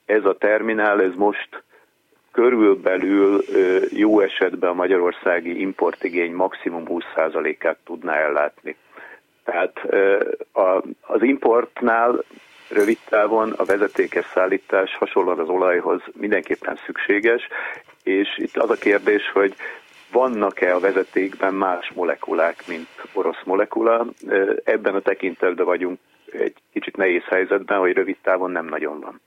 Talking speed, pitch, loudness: 115 wpm, 375 Hz, -20 LUFS